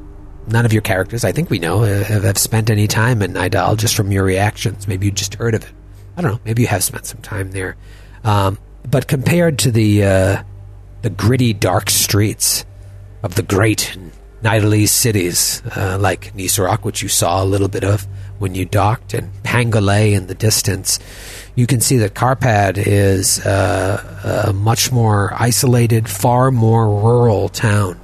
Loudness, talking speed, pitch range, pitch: -15 LUFS, 175 wpm, 100-115 Hz, 105 Hz